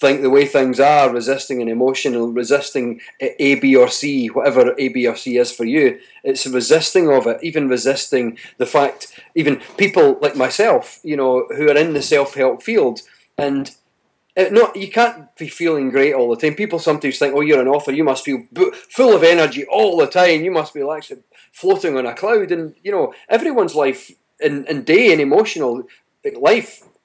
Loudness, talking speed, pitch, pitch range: -16 LUFS, 195 wpm, 145 Hz, 135-195 Hz